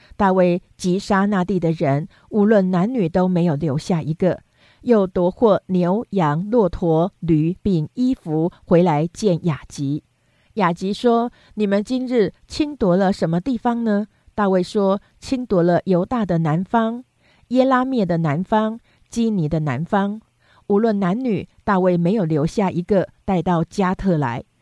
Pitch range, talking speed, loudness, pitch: 170-215 Hz, 215 characters per minute, -20 LUFS, 185 Hz